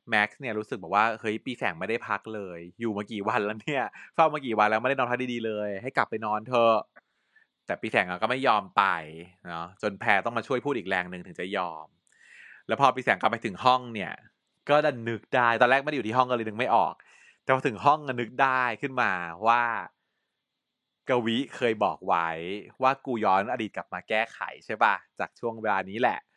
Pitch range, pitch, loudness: 105-130 Hz, 115 Hz, -27 LUFS